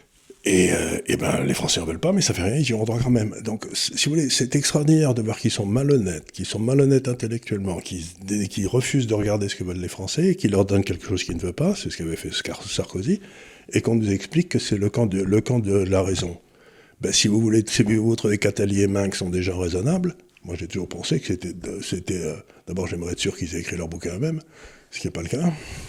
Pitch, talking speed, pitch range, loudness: 105 Hz, 255 wpm, 95-125 Hz, -23 LUFS